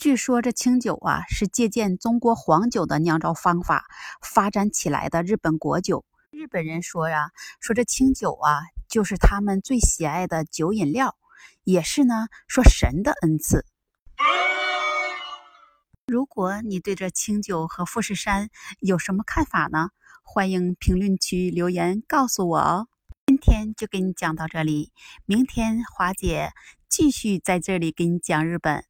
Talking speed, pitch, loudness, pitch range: 225 characters per minute, 190 Hz, -23 LUFS, 170-230 Hz